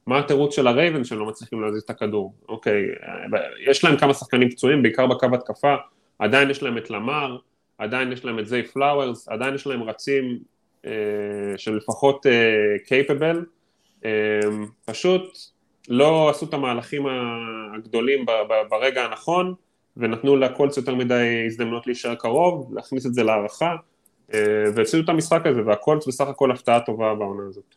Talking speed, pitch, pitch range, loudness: 150 wpm, 125 Hz, 110-140 Hz, -22 LUFS